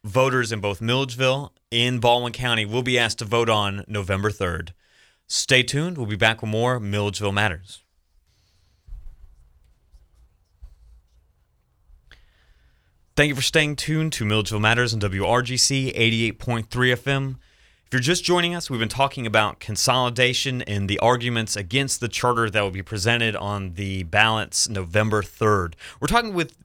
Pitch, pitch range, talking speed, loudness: 110 Hz, 95-125 Hz, 145 wpm, -22 LUFS